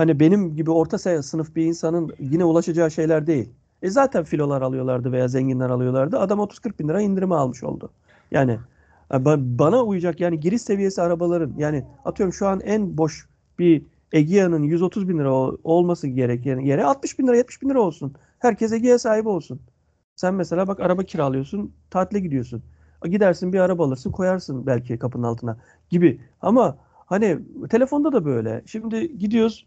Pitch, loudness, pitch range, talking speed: 165 Hz, -21 LUFS, 135-195 Hz, 160 wpm